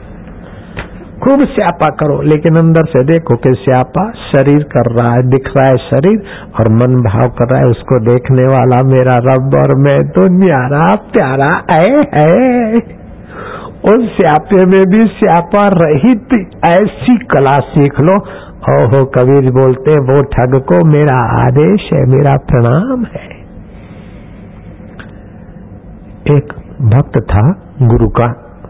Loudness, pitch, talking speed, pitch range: -9 LUFS, 140 Hz, 130 wpm, 125-180 Hz